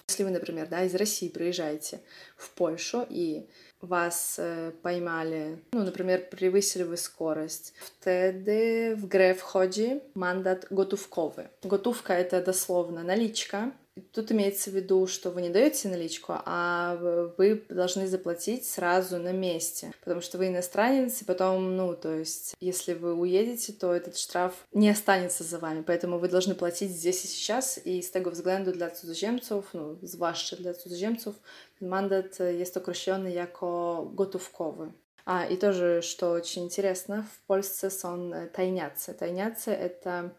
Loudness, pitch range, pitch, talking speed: -29 LUFS, 175-195 Hz, 185 Hz, 145 wpm